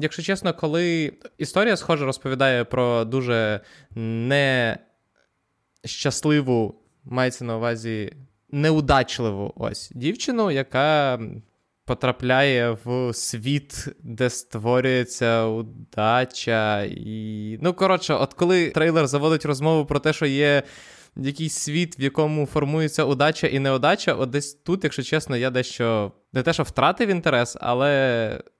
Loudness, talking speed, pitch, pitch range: -22 LUFS, 115 wpm, 135 Hz, 120-155 Hz